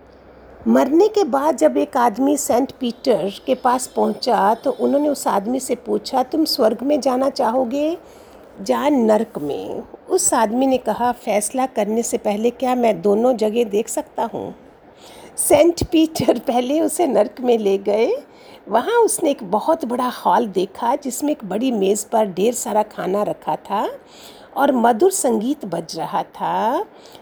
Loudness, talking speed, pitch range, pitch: -19 LUFS, 160 wpm, 215-290 Hz, 250 Hz